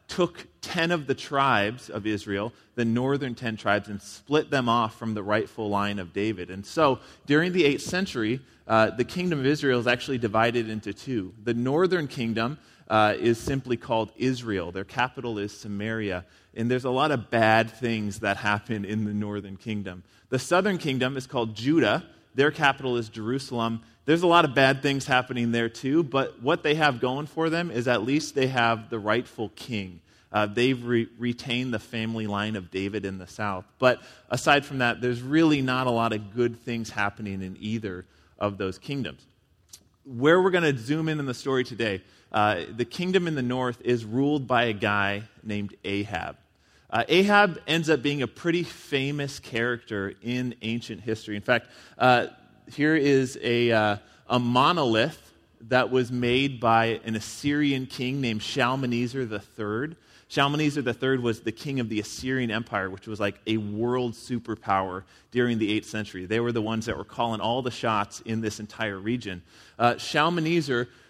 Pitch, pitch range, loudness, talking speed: 120 Hz, 105-135 Hz, -26 LUFS, 180 wpm